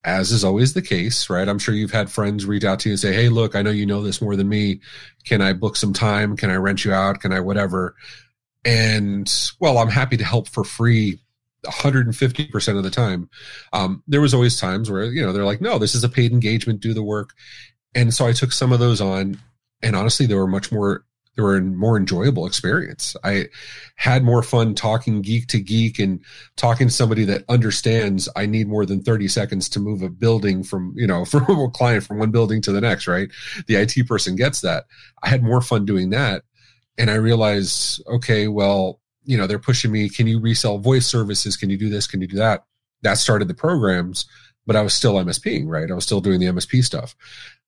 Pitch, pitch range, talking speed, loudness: 110 Hz, 100-120 Hz, 225 wpm, -19 LUFS